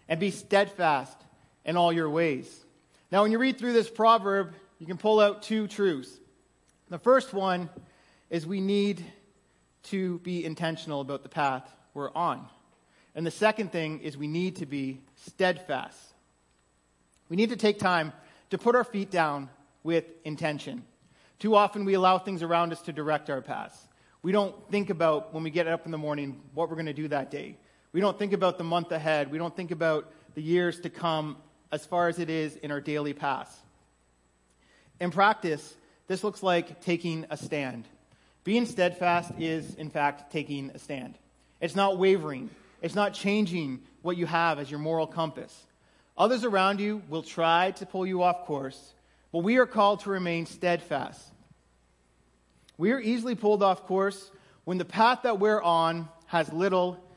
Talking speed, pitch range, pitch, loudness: 175 wpm, 150-195 Hz, 170 Hz, -28 LUFS